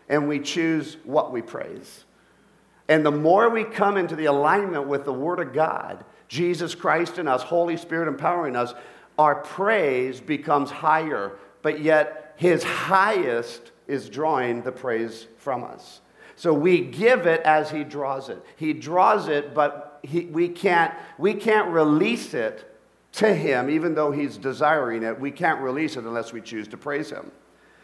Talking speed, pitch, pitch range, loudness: 165 wpm, 155 Hz, 140-170 Hz, -23 LUFS